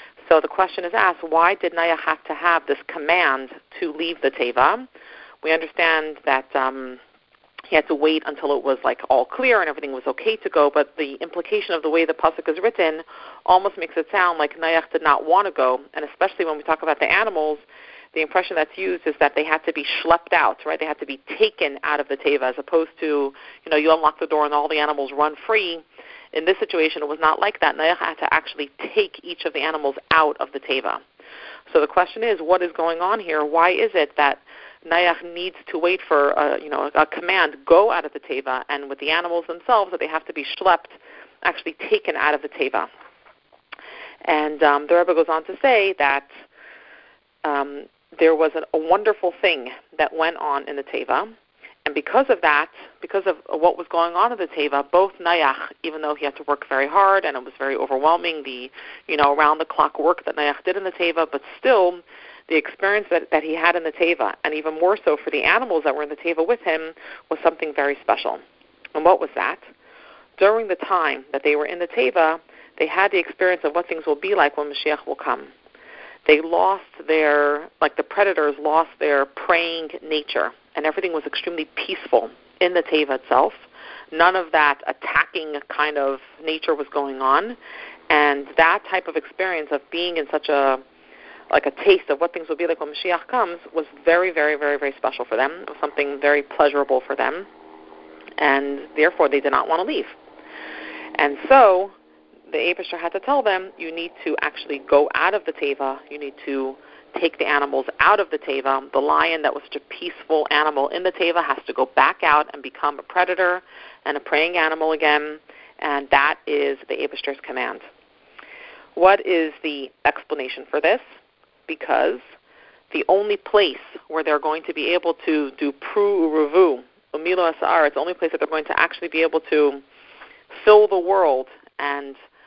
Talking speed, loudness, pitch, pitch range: 205 wpm, -20 LUFS, 160 Hz, 150-185 Hz